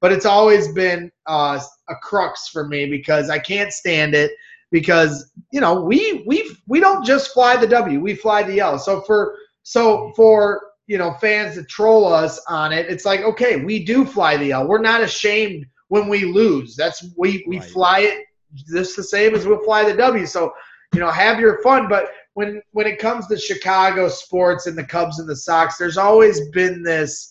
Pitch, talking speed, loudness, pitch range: 200 Hz, 205 wpm, -17 LUFS, 170-215 Hz